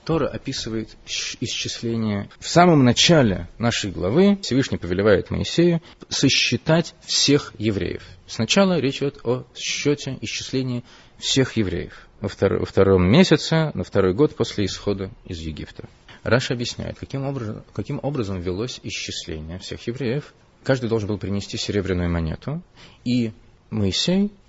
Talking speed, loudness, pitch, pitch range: 120 wpm, -21 LUFS, 115 Hz, 100-140 Hz